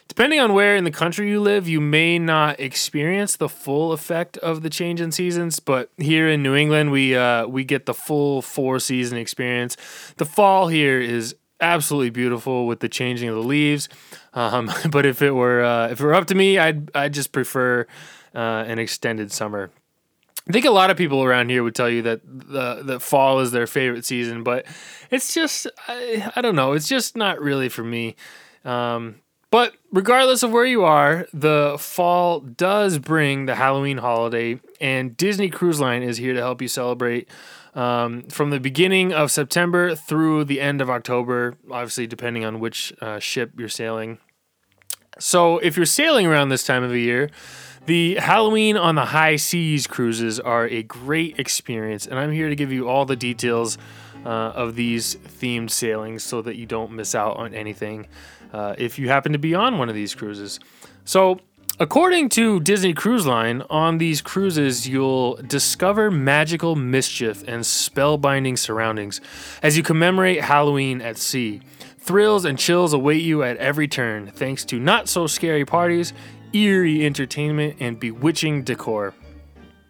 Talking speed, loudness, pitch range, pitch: 175 wpm, -20 LUFS, 120-165 Hz, 135 Hz